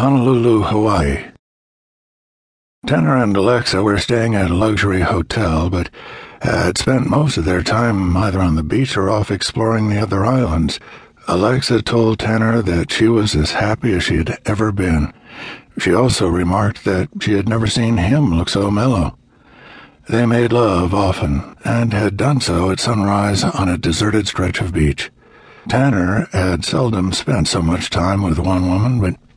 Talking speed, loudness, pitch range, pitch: 165 wpm, -16 LUFS, 90-115 Hz, 100 Hz